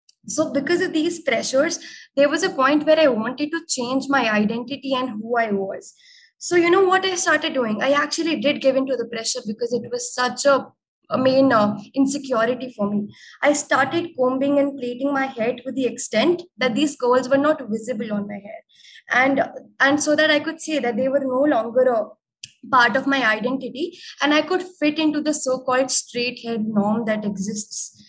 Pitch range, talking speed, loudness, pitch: 240-300 Hz, 200 wpm, -20 LUFS, 265 Hz